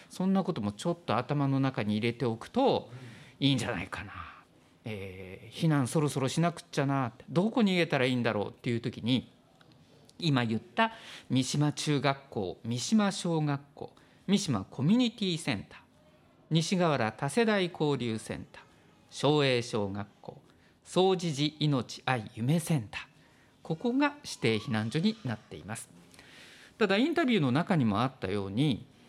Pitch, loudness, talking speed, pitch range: 135 Hz, -30 LUFS, 315 characters per minute, 115-170 Hz